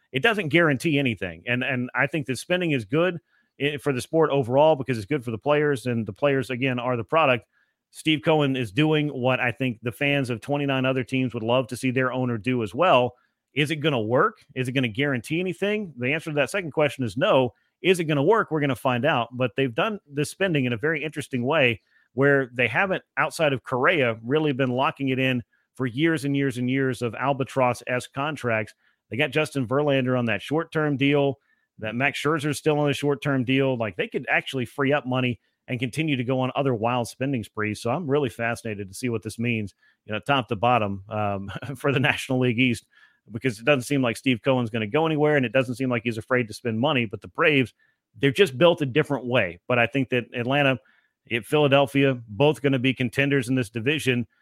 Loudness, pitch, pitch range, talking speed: -24 LUFS, 130 Hz, 120-145 Hz, 230 wpm